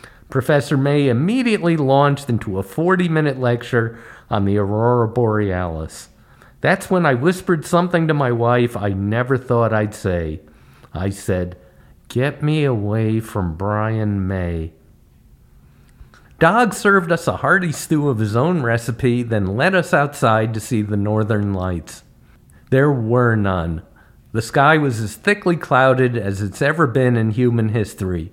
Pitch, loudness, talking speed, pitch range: 120 Hz, -18 LUFS, 145 wpm, 105-145 Hz